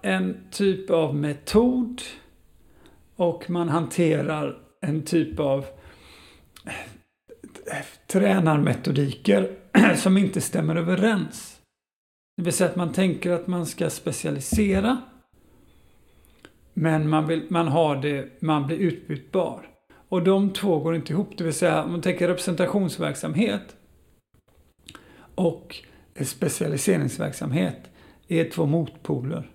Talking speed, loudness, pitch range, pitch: 105 wpm, -24 LUFS, 155-185 Hz, 170 Hz